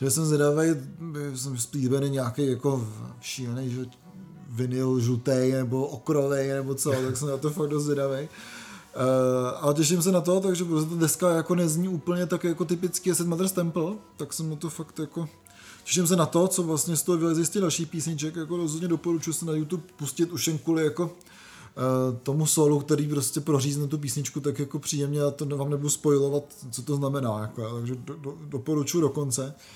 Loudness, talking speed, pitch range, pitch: -26 LUFS, 190 wpm, 135-165 Hz, 150 Hz